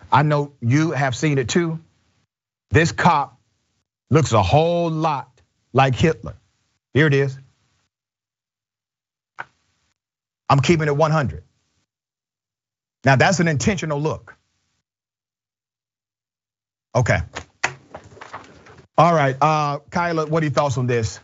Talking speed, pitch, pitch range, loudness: 105 wpm, 130 Hz, 110-150 Hz, -19 LUFS